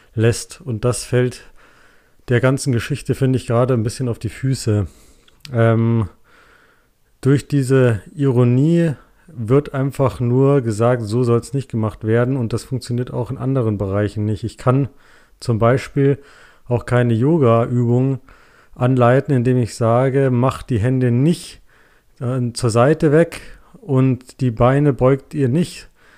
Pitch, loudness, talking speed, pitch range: 125 Hz, -18 LUFS, 140 wpm, 115-135 Hz